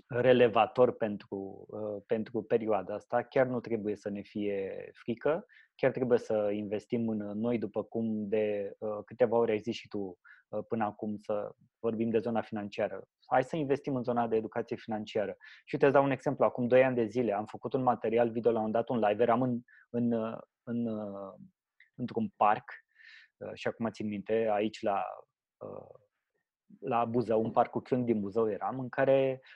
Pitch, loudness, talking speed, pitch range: 115 Hz, -32 LUFS, 180 wpm, 105-125 Hz